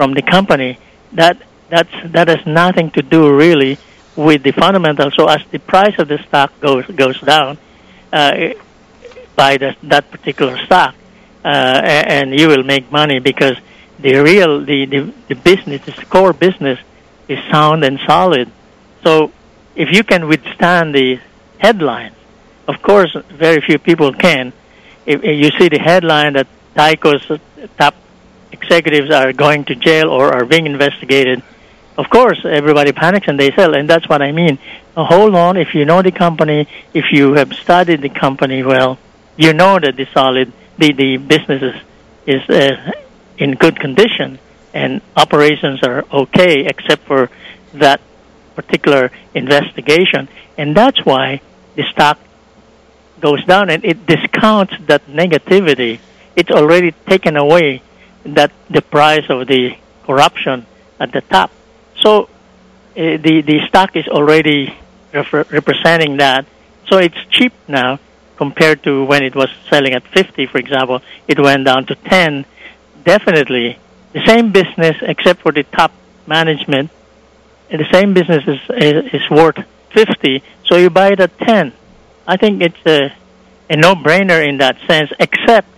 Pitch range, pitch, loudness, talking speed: 140-170 Hz, 150 Hz, -11 LUFS, 150 wpm